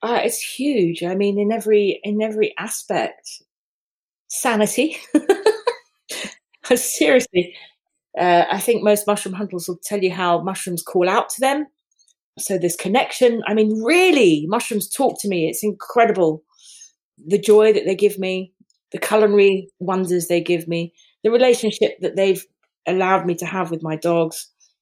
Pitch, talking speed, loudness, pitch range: 205 Hz, 150 wpm, -19 LUFS, 180-230 Hz